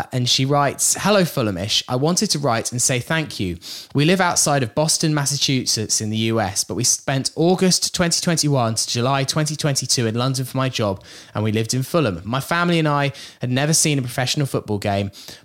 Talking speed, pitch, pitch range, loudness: 200 wpm, 135 Hz, 115-155 Hz, -19 LUFS